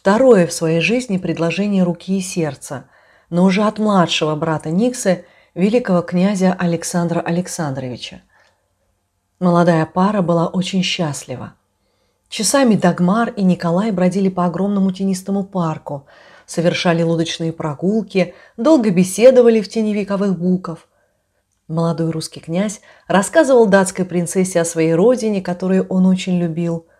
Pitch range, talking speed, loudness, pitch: 165-195 Hz, 120 wpm, -16 LUFS, 180 Hz